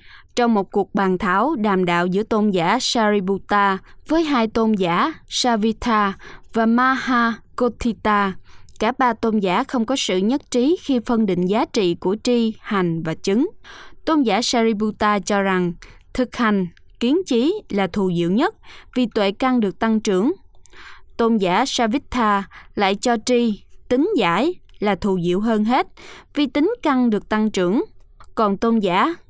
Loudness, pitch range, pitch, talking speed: -20 LUFS, 200-250 Hz, 225 Hz, 160 wpm